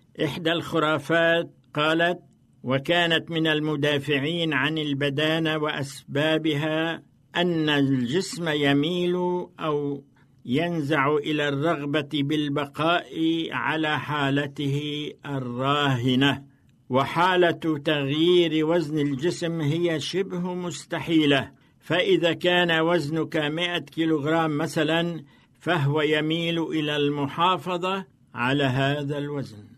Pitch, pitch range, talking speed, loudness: 155 Hz, 145-165 Hz, 80 wpm, -24 LUFS